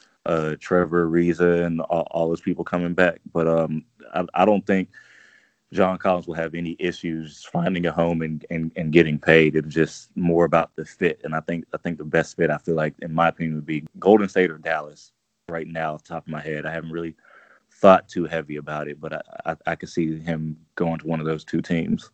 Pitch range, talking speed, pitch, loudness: 80-85 Hz, 235 wpm, 80 Hz, -23 LUFS